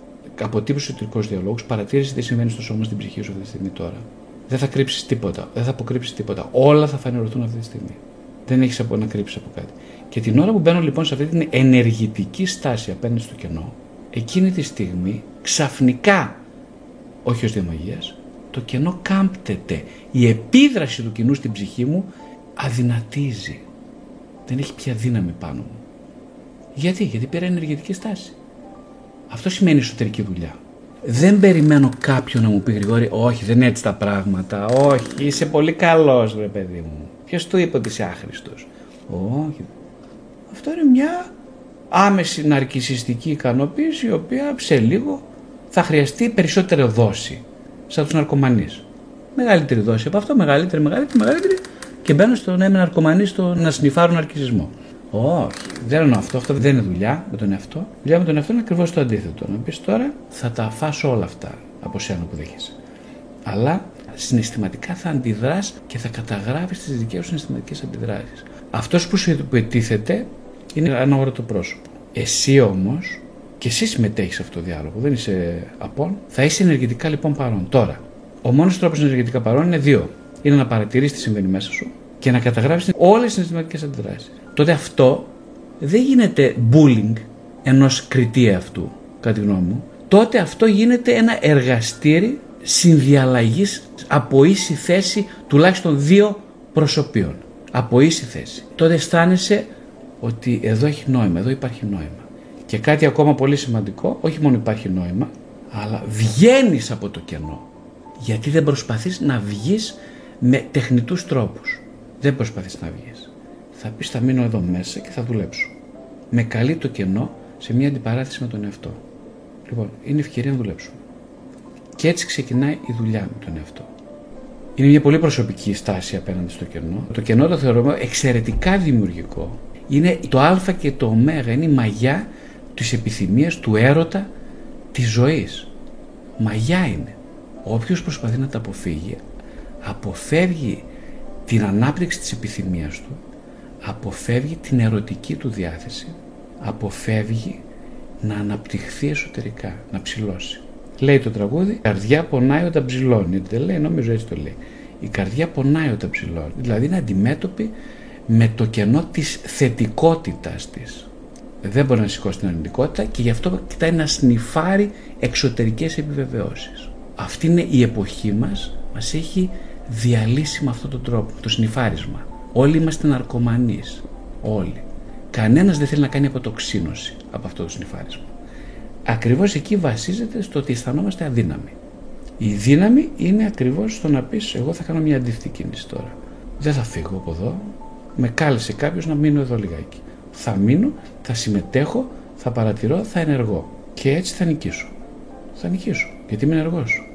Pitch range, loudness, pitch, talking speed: 115-170 Hz, -19 LUFS, 135 Hz, 155 wpm